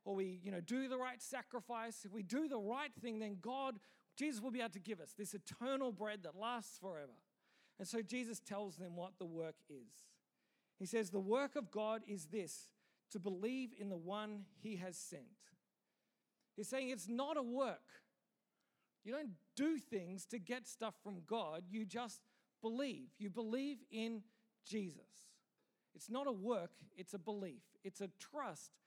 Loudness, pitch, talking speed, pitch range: -46 LUFS, 220 Hz, 180 wpm, 200-250 Hz